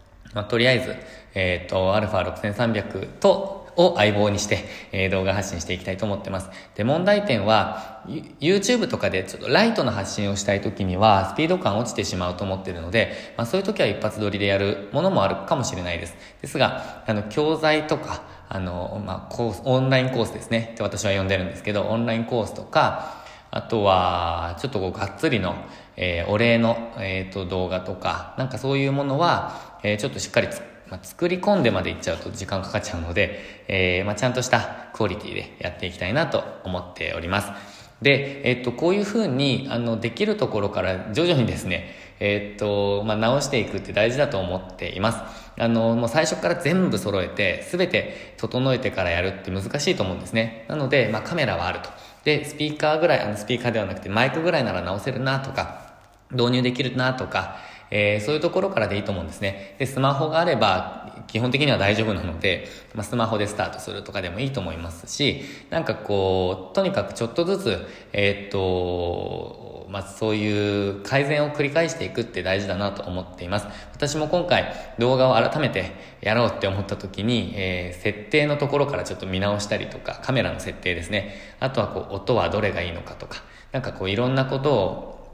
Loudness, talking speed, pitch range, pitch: -23 LUFS, 425 characters per minute, 95-130 Hz, 105 Hz